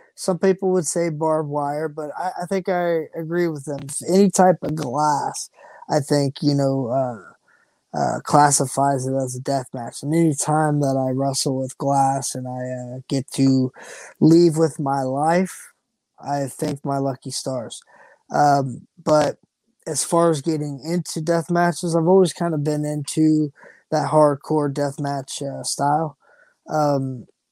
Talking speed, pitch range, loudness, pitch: 160 wpm, 140-165 Hz, -21 LUFS, 150 Hz